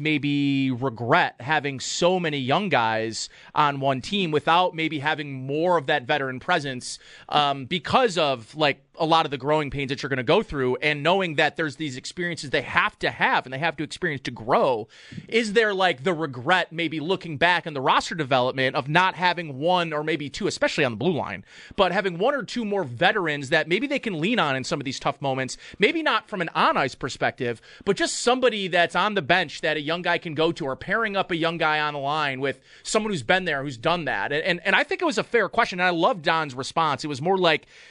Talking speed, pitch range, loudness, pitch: 235 wpm, 140-180 Hz, -23 LUFS, 160 Hz